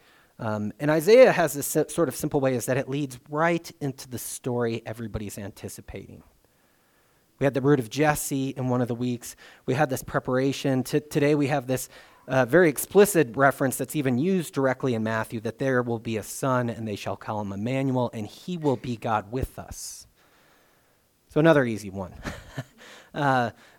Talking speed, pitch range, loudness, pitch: 185 wpm, 115-145 Hz, -25 LUFS, 130 Hz